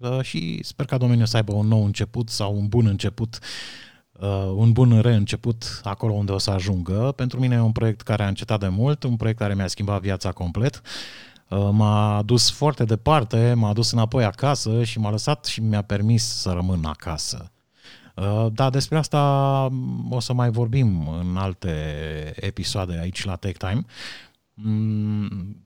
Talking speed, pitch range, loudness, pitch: 160 wpm, 100-120 Hz, -22 LUFS, 110 Hz